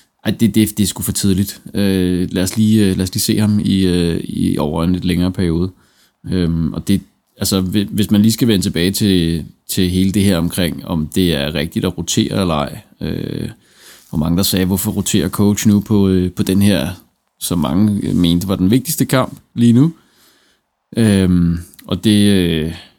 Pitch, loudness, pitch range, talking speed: 95 Hz, -16 LUFS, 90-105 Hz, 195 wpm